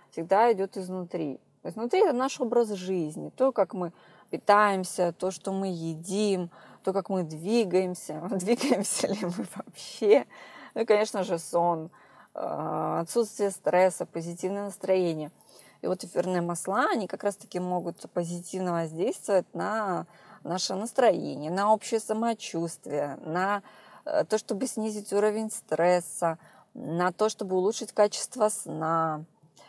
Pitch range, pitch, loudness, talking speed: 175-215 Hz, 190 Hz, -28 LUFS, 125 wpm